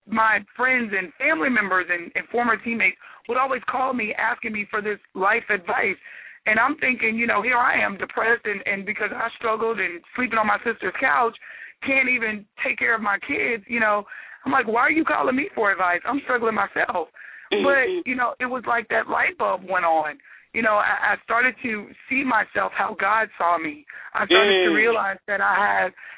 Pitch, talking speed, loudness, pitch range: 225 Hz, 205 wpm, -22 LUFS, 205-250 Hz